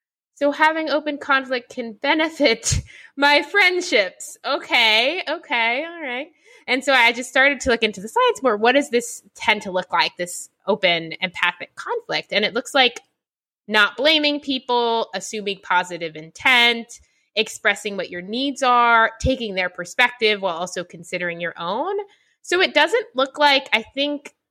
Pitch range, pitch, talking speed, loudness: 210-290 Hz, 245 Hz, 155 wpm, -19 LUFS